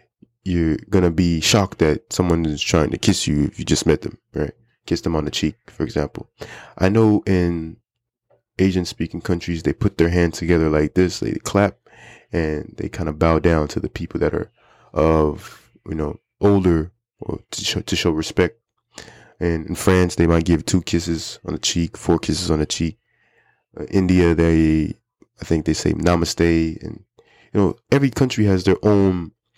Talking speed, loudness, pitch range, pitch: 190 wpm, -20 LUFS, 80-95 Hz, 85 Hz